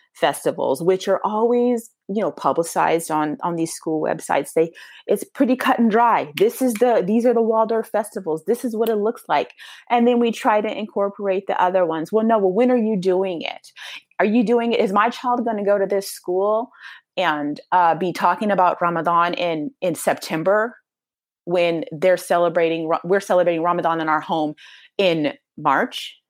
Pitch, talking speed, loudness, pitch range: 200 Hz, 185 wpm, -20 LUFS, 175-230 Hz